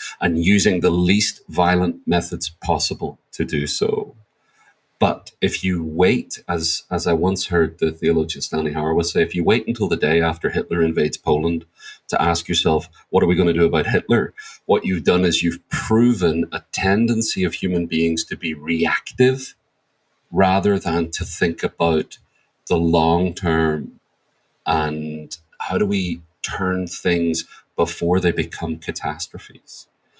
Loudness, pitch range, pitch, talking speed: -20 LUFS, 80-90 Hz, 85 Hz, 155 wpm